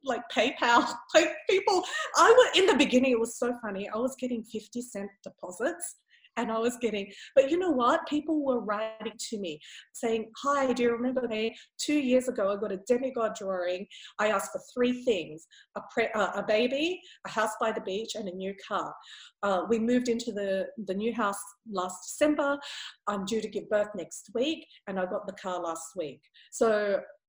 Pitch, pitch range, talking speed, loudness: 230 Hz, 200-275 Hz, 200 wpm, -29 LUFS